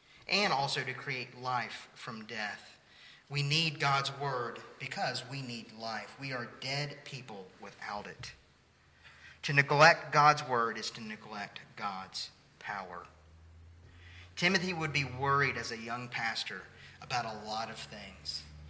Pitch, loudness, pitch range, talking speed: 125 Hz, -32 LUFS, 110-145 Hz, 140 wpm